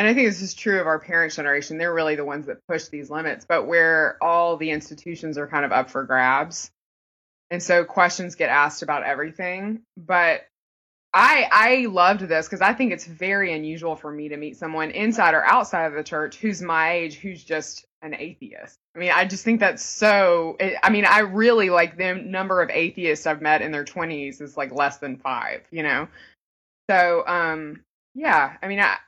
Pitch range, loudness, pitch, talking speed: 150-185 Hz, -21 LUFS, 165 Hz, 205 wpm